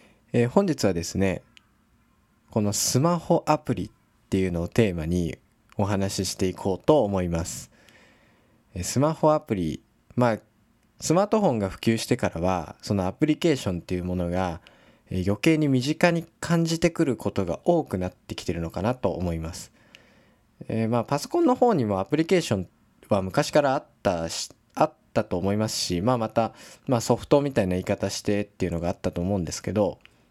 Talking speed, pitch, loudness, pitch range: 360 characters per minute, 105 Hz, -25 LUFS, 90-125 Hz